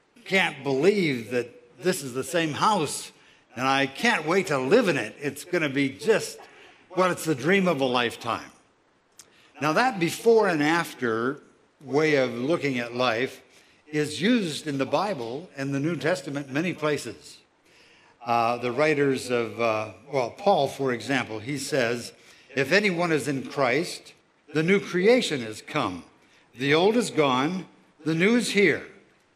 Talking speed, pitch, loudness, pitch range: 160 wpm, 145 Hz, -25 LUFS, 130-175 Hz